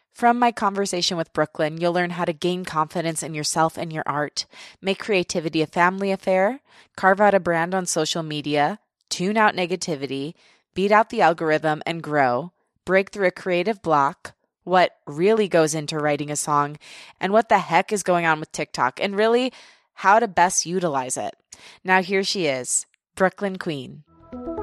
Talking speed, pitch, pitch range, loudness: 175 wpm, 175 Hz, 155-195 Hz, -22 LUFS